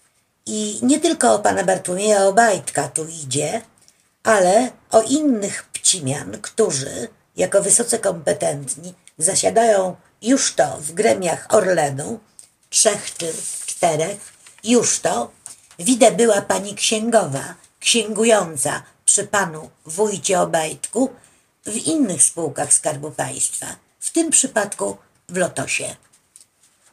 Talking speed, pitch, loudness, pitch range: 105 wpm, 200 Hz, -18 LUFS, 160-225 Hz